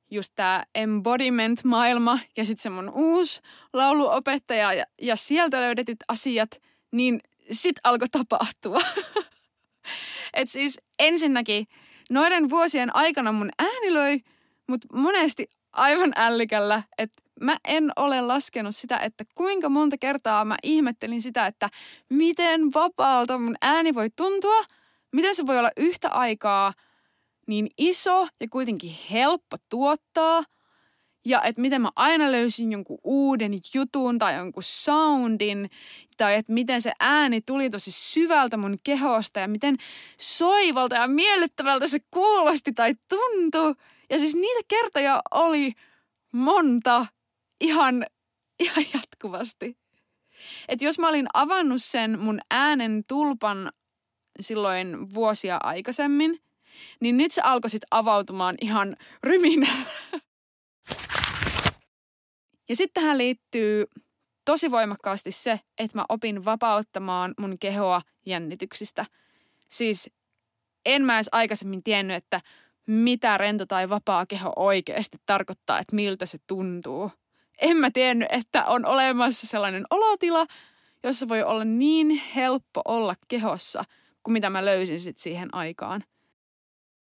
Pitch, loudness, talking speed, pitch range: 250 Hz, -24 LUFS, 120 wpm, 215-305 Hz